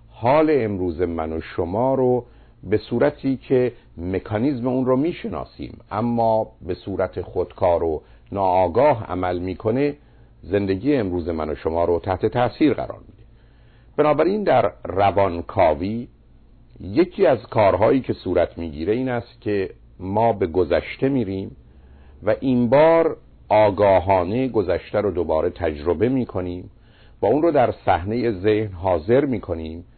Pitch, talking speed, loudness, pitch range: 105 Hz, 130 wpm, -21 LUFS, 90-120 Hz